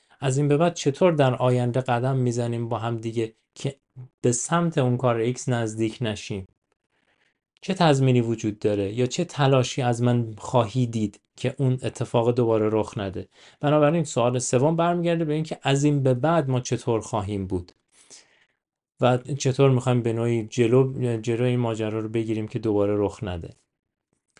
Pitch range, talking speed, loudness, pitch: 110-135 Hz, 160 wpm, -24 LUFS, 125 Hz